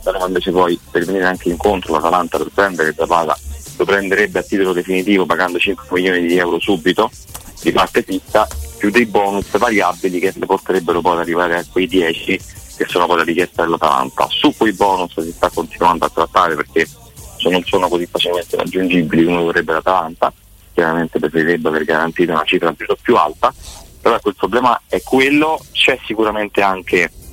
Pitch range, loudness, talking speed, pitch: 85-95 Hz, -15 LUFS, 175 wpm, 90 Hz